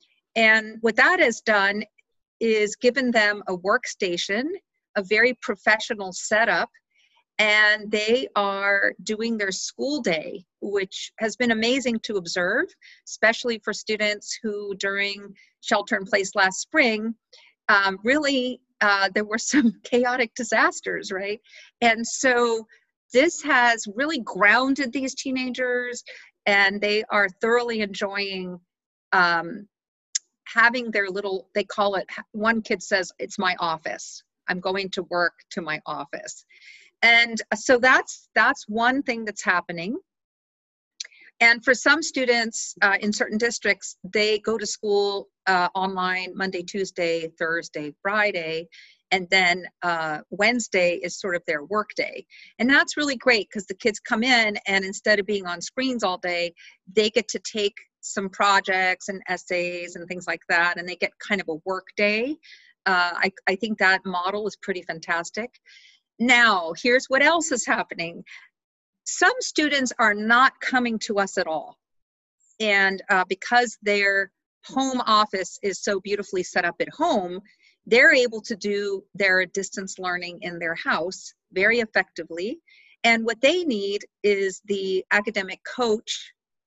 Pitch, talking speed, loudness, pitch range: 210 Hz, 145 wpm, -22 LUFS, 190-245 Hz